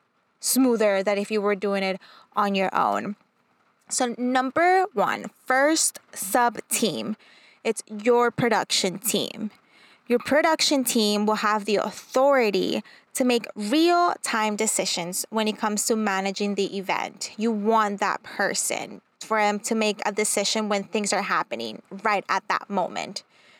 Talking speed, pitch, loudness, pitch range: 145 wpm, 215 Hz, -24 LUFS, 205-245 Hz